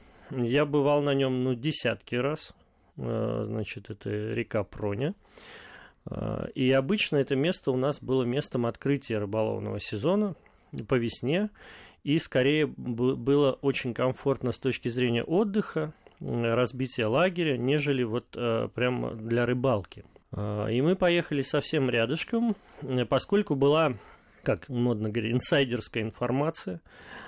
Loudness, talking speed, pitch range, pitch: -28 LUFS, 115 wpm, 115-145 Hz, 130 Hz